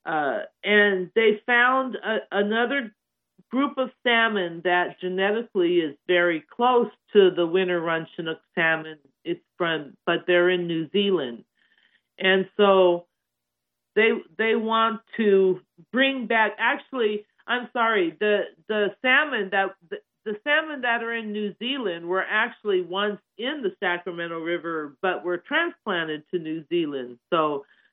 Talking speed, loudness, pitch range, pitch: 135 wpm, -24 LUFS, 175-230 Hz, 195 Hz